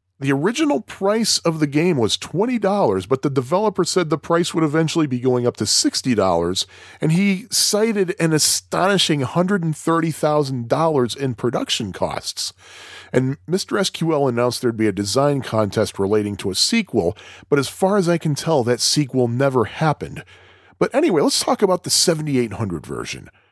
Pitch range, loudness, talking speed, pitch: 125-185 Hz, -19 LUFS, 160 wpm, 150 Hz